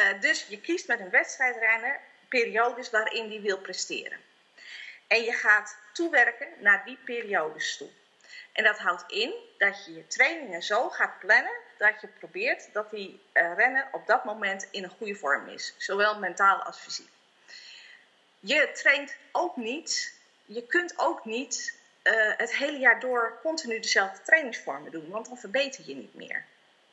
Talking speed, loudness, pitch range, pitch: 155 wpm, -26 LUFS, 210-285 Hz, 235 Hz